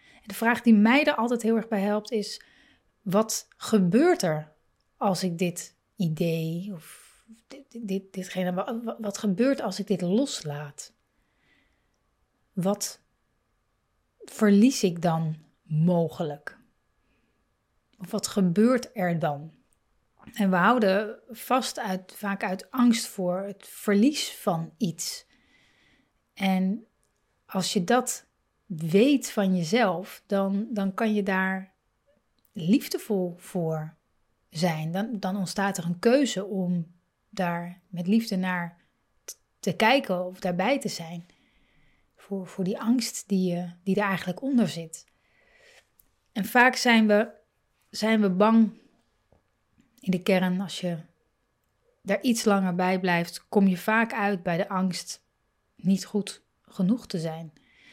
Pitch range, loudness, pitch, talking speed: 180-225 Hz, -26 LUFS, 200 Hz, 125 wpm